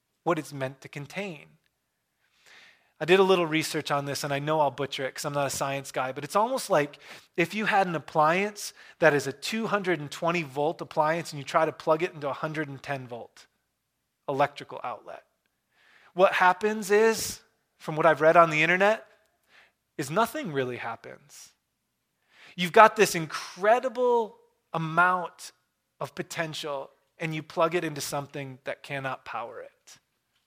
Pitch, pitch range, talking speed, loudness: 160 Hz, 145-190 Hz, 160 wpm, -26 LUFS